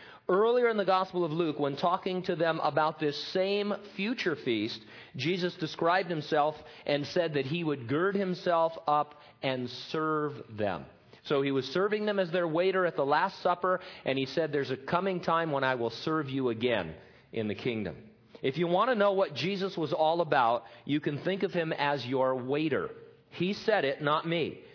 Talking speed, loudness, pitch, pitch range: 195 wpm, -30 LUFS, 160 Hz, 140-185 Hz